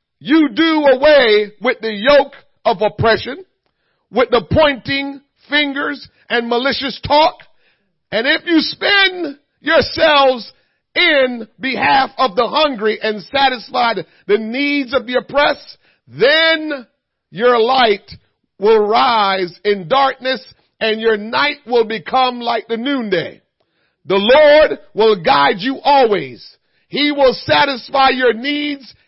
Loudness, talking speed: -14 LUFS, 120 wpm